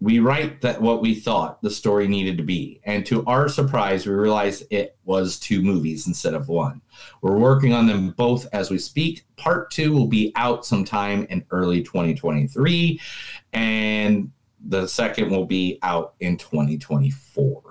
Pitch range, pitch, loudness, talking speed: 95-125 Hz, 105 Hz, -22 LUFS, 180 wpm